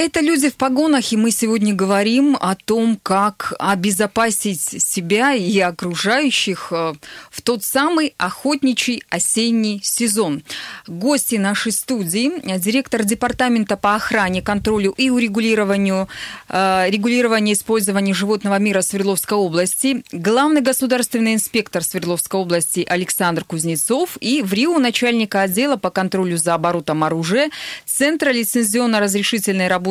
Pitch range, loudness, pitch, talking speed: 190-245 Hz, -17 LUFS, 210 Hz, 115 wpm